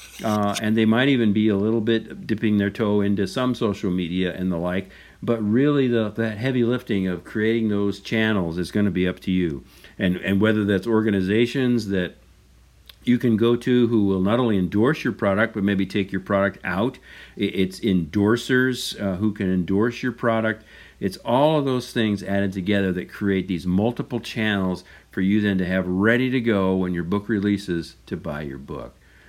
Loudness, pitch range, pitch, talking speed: -22 LUFS, 95-115 Hz, 105 Hz, 195 wpm